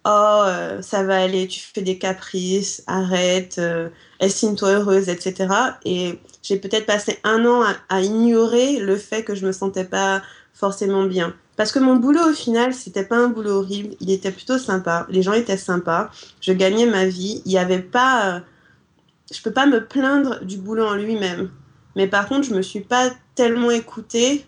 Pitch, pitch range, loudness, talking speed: 200 Hz, 190-230 Hz, -20 LUFS, 190 wpm